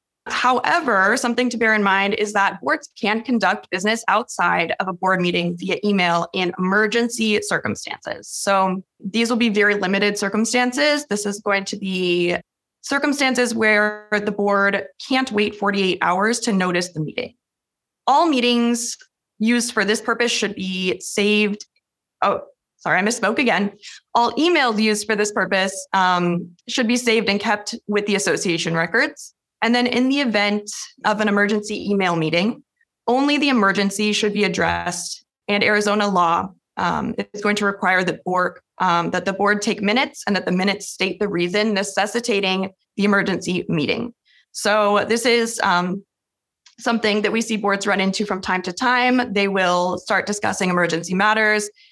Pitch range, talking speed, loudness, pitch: 190-230 Hz, 160 wpm, -19 LUFS, 205 Hz